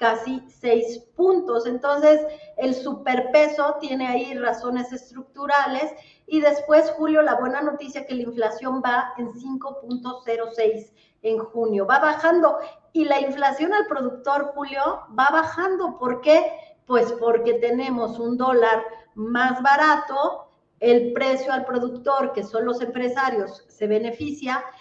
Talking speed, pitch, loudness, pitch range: 130 wpm, 260 Hz, -22 LUFS, 240-290 Hz